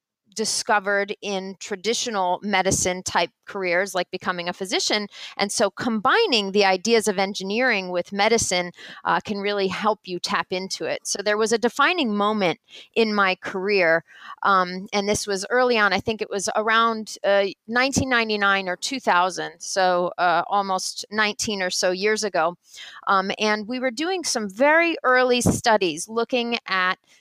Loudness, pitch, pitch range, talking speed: -22 LUFS, 200 Hz, 185-225 Hz, 155 wpm